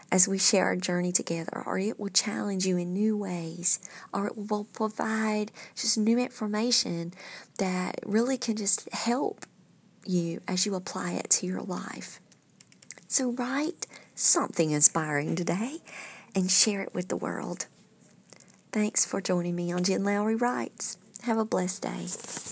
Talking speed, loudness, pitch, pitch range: 150 wpm, -27 LUFS, 200 Hz, 180-220 Hz